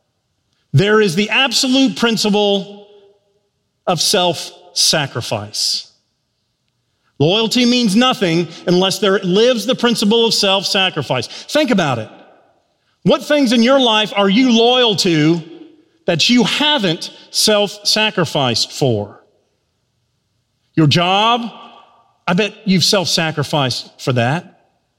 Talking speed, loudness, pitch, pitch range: 110 wpm, -14 LUFS, 195 Hz, 145-230 Hz